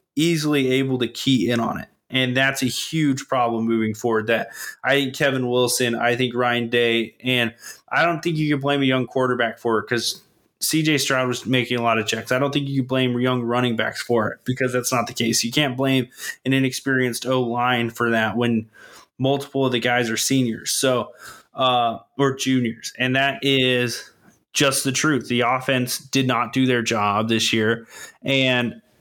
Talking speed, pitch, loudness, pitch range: 195 wpm, 125 Hz, -21 LUFS, 120-135 Hz